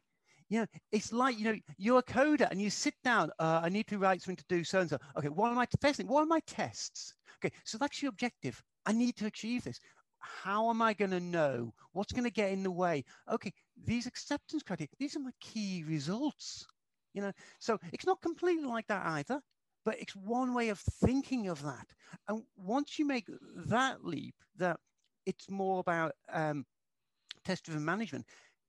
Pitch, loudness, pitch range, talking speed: 210 Hz, -35 LUFS, 180-250 Hz, 200 wpm